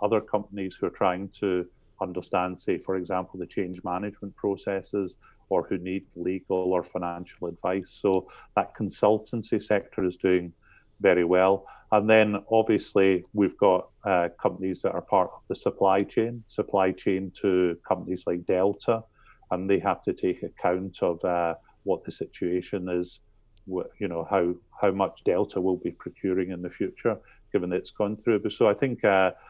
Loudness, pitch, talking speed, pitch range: -27 LUFS, 95 Hz, 165 wpm, 90-100 Hz